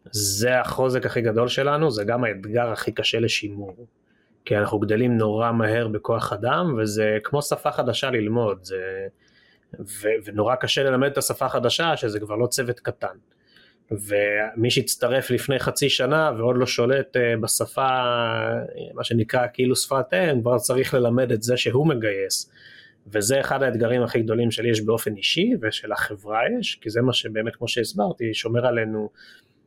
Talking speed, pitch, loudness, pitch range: 155 wpm, 120 Hz, -22 LUFS, 110-130 Hz